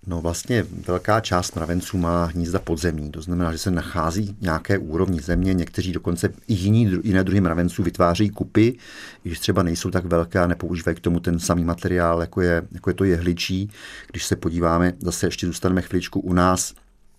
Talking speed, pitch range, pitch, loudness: 180 wpm, 85-95 Hz, 90 Hz, -22 LUFS